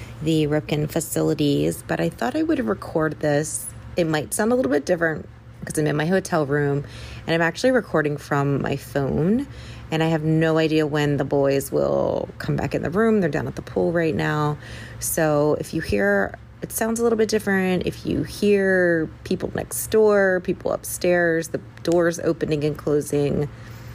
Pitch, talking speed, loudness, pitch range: 155 Hz, 185 wpm, -22 LUFS, 145-175 Hz